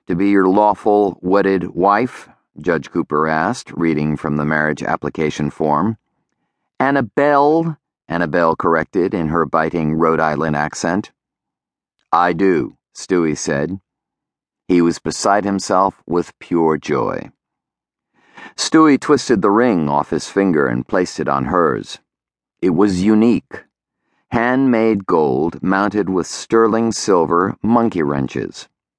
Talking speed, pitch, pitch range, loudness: 120 wpm, 90 Hz, 80-105 Hz, -17 LUFS